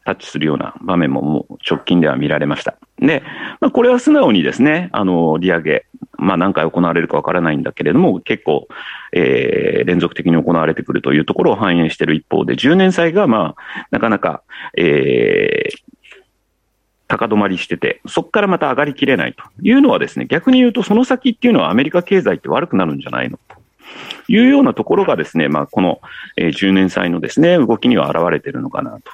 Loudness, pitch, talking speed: -15 LUFS, 195 Hz, 405 characters per minute